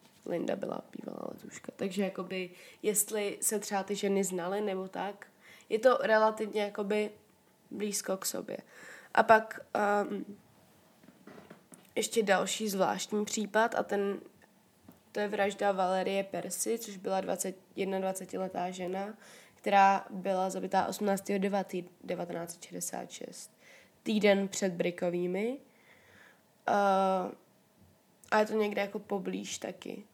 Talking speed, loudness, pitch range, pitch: 110 wpm, -32 LUFS, 190-210 Hz, 200 Hz